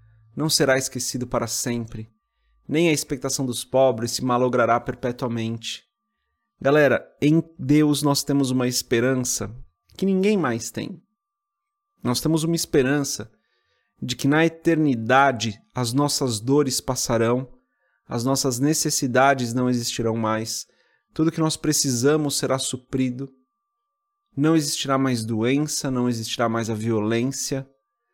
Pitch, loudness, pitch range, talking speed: 130 Hz, -22 LUFS, 120-150 Hz, 125 wpm